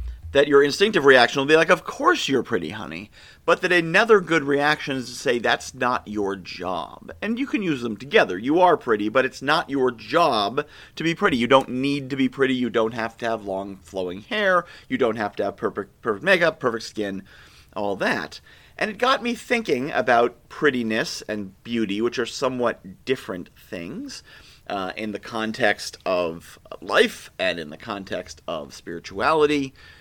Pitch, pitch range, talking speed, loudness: 130 Hz, 110-165 Hz, 185 wpm, -22 LUFS